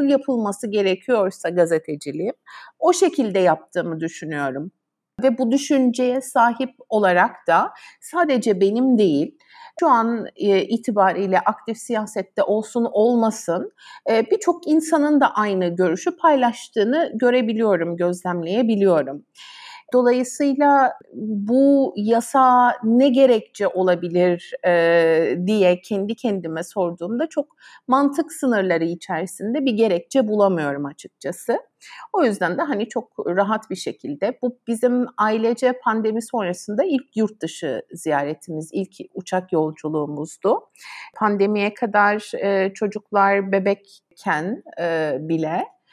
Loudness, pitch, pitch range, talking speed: -20 LUFS, 215 Hz, 180-255 Hz, 100 wpm